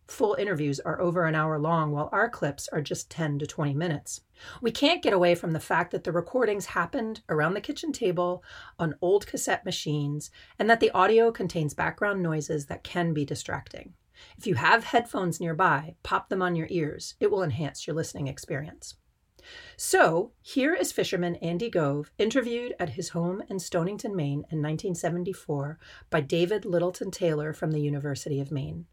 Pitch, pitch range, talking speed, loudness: 175 Hz, 155-205 Hz, 180 wpm, -28 LUFS